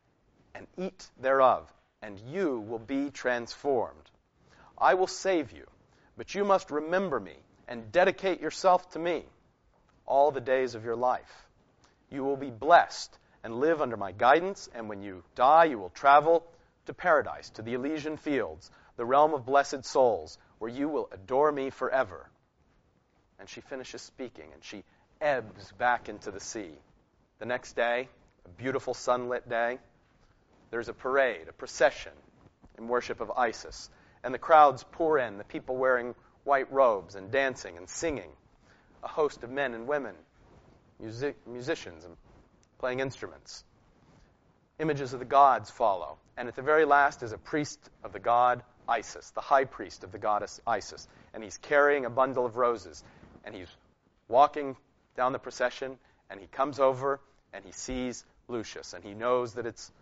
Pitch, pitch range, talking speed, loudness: 130 Hz, 120-145 Hz, 165 wpm, -28 LUFS